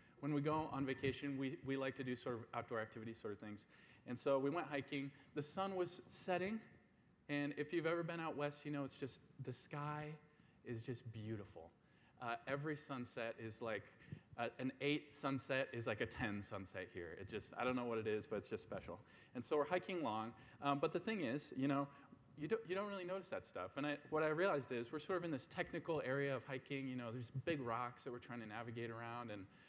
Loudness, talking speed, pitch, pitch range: -45 LUFS, 235 wpm, 135 Hz, 120-150 Hz